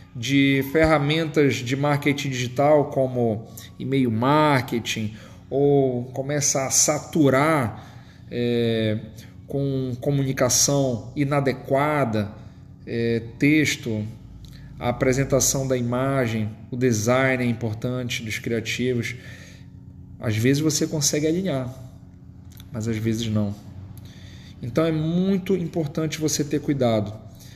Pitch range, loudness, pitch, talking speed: 115-145 Hz, -22 LUFS, 130 Hz, 95 wpm